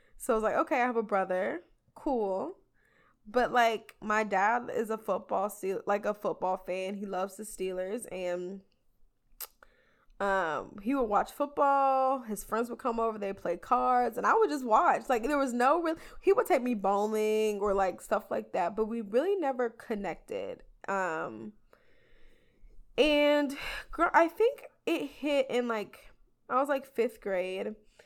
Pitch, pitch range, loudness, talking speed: 225 Hz, 195-275 Hz, -30 LUFS, 170 wpm